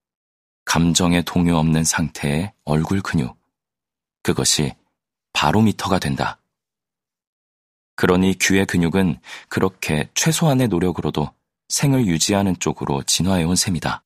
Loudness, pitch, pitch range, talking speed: -19 LUFS, 85 Hz, 75-95 Hz, 255 characters per minute